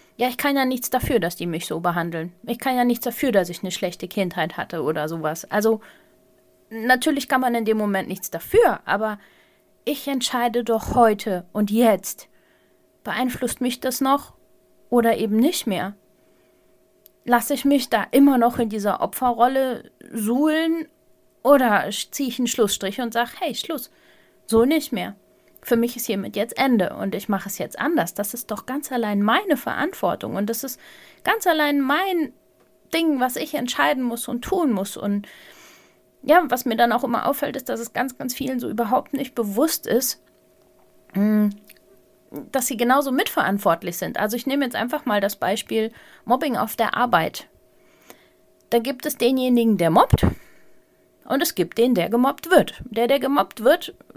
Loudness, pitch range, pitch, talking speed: -22 LUFS, 205-270 Hz, 240 Hz, 175 wpm